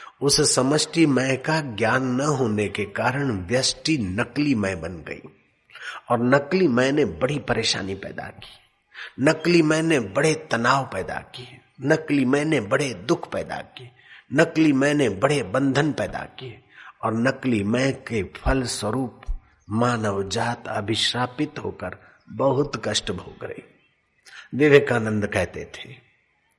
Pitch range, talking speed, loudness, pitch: 115-145 Hz, 130 wpm, -22 LUFS, 130 Hz